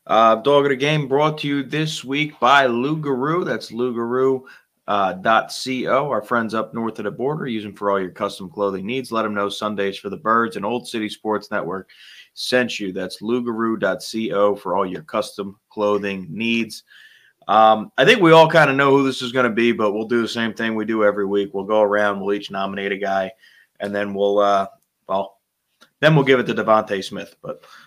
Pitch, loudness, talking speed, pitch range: 110 Hz, -19 LUFS, 210 wpm, 100-130 Hz